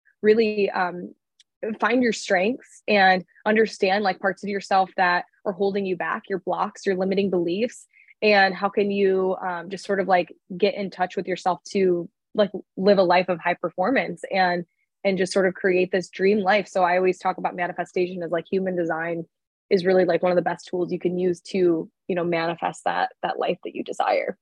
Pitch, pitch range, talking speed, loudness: 185 Hz, 180-200 Hz, 205 wpm, -23 LUFS